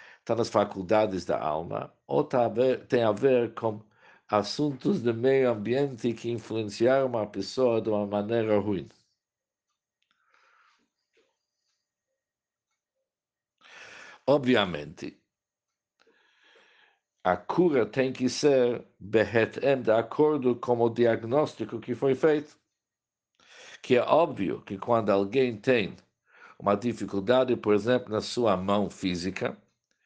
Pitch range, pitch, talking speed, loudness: 105-130 Hz, 120 Hz, 110 wpm, -27 LUFS